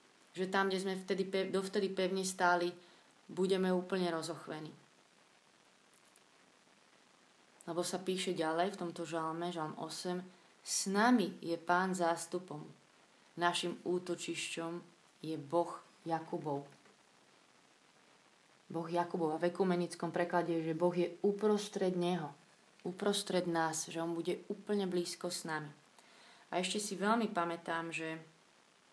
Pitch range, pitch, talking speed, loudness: 165-190 Hz, 175 Hz, 120 wpm, -37 LUFS